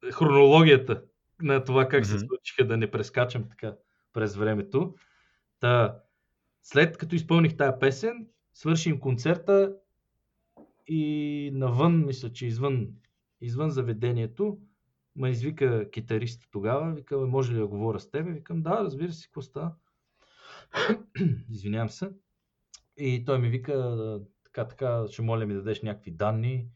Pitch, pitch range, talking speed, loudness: 130 Hz, 115-160 Hz, 130 wpm, -27 LUFS